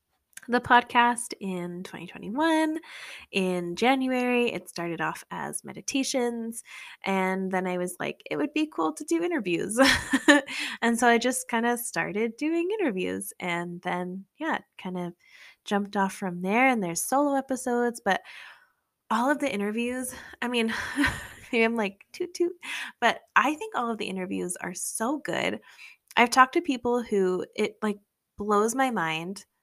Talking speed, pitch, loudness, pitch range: 155 wpm, 235 Hz, -27 LUFS, 190-265 Hz